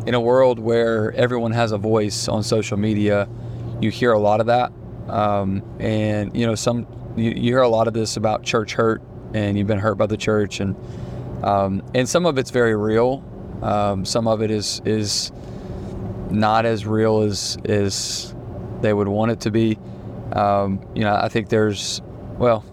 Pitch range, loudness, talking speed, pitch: 105-115 Hz, -20 LUFS, 185 wpm, 110 Hz